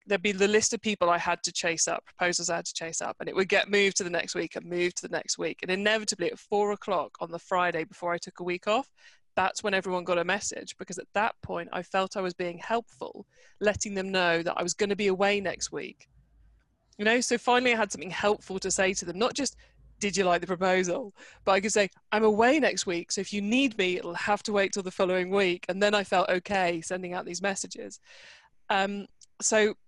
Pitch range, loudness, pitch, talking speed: 180-210 Hz, -28 LUFS, 195 Hz, 250 wpm